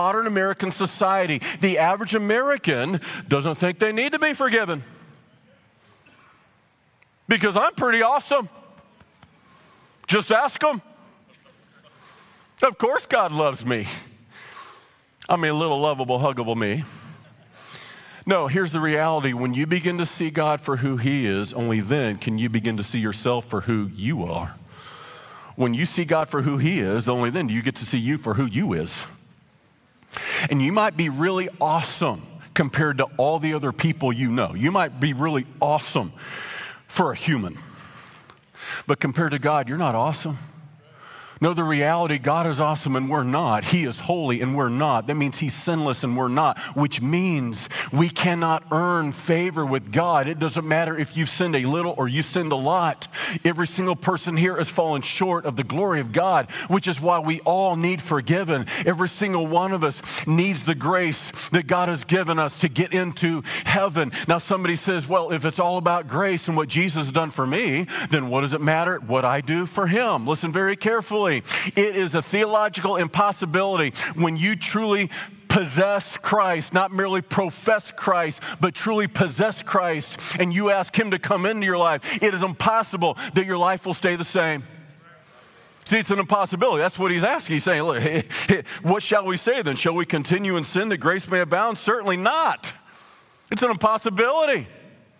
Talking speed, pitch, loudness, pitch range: 180 wpm, 170 Hz, -22 LUFS, 145-190 Hz